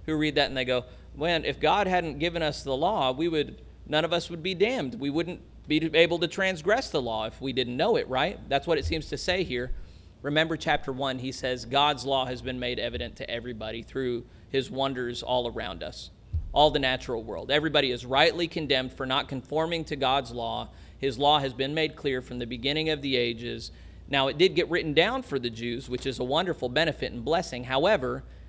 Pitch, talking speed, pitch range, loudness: 135 Hz, 225 wpm, 125-155 Hz, -27 LUFS